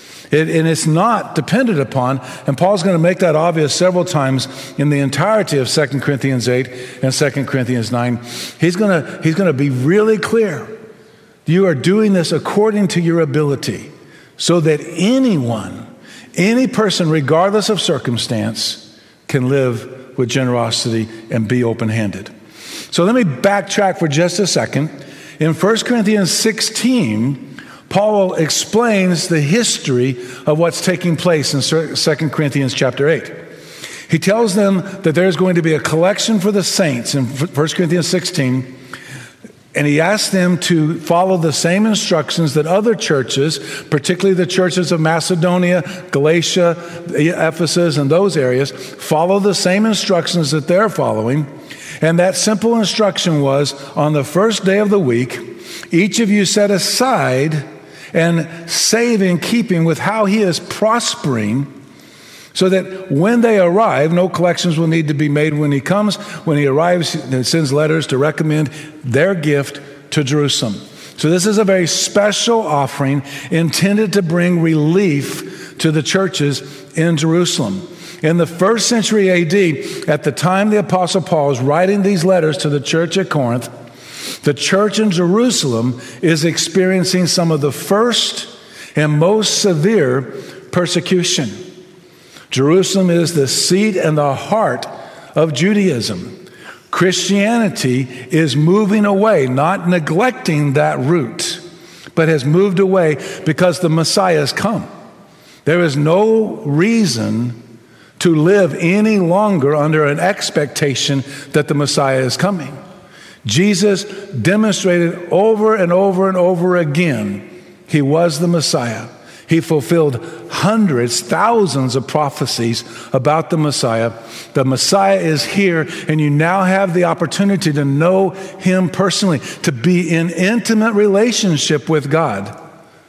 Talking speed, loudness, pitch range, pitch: 140 wpm, -15 LUFS, 145-190 Hz, 170 Hz